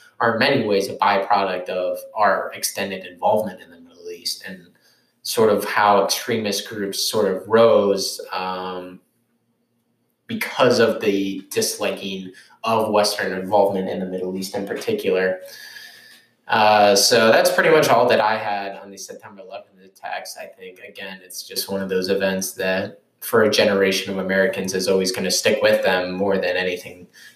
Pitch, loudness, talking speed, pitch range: 100 Hz, -19 LUFS, 165 wpm, 95-115 Hz